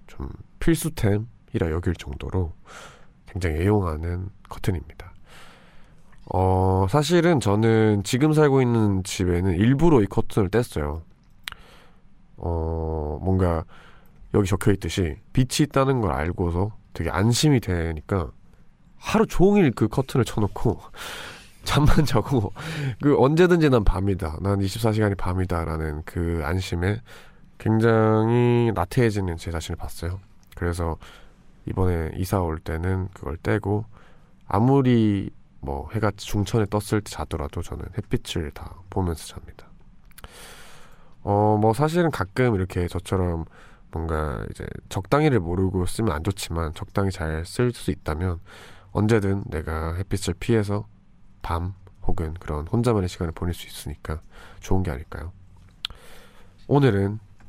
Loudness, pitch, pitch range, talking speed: -24 LUFS, 95 Hz, 85-110 Hz, 260 characters per minute